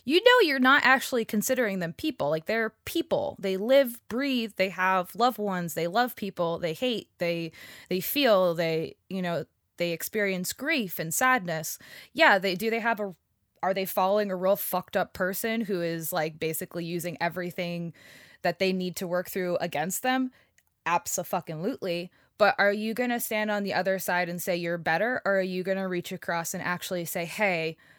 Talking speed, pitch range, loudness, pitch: 195 wpm, 175-225 Hz, -27 LUFS, 190 Hz